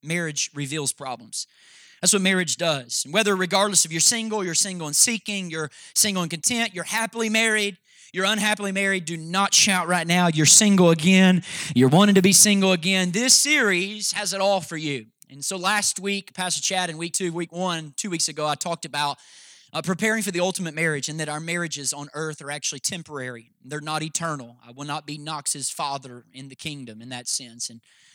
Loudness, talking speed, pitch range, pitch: -21 LUFS, 205 wpm, 150-195 Hz, 170 Hz